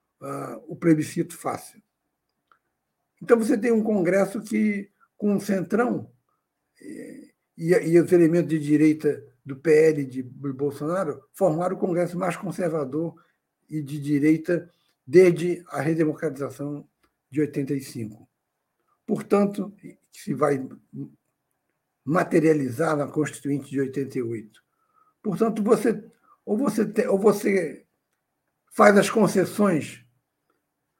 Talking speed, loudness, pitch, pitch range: 105 wpm, -23 LUFS, 170 Hz, 145-205 Hz